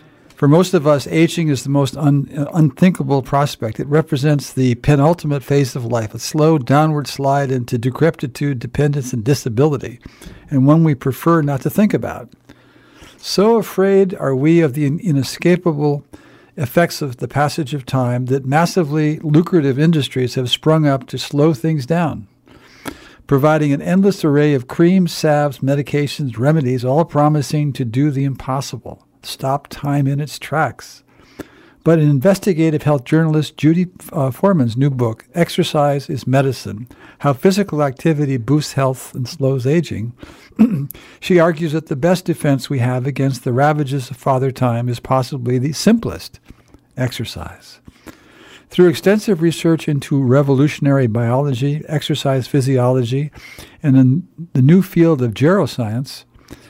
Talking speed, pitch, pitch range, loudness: 140 wpm, 145 Hz, 130-160 Hz, -16 LUFS